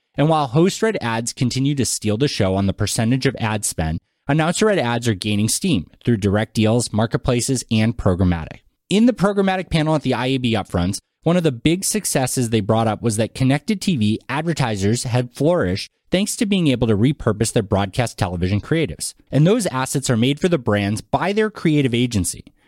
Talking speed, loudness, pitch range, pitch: 195 wpm, -19 LUFS, 110-155 Hz, 125 Hz